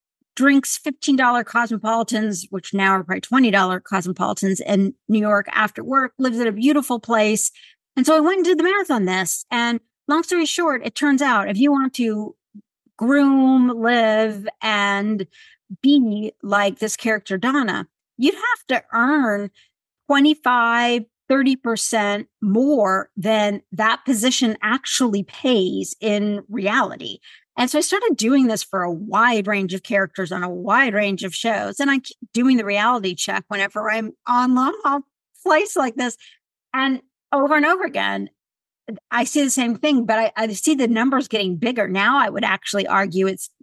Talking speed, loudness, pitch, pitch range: 160 wpm, -19 LUFS, 230 Hz, 205-270 Hz